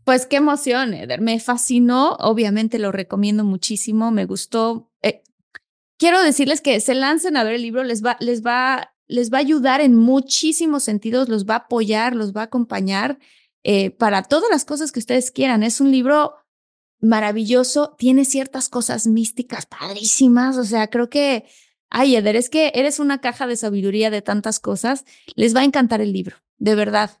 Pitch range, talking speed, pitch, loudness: 220-270 Hz, 180 wpm, 245 Hz, -18 LUFS